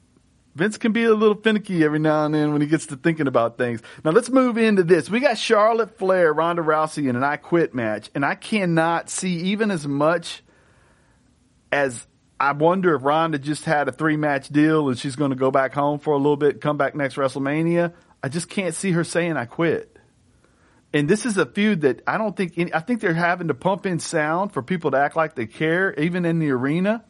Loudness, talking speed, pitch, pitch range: -21 LUFS, 230 wpm, 160 Hz, 145-190 Hz